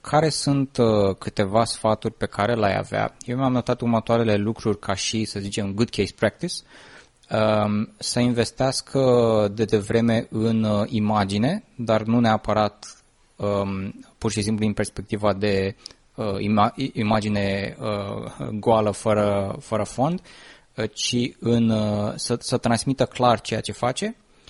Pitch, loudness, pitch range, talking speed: 110 Hz, -23 LUFS, 105-120 Hz, 120 wpm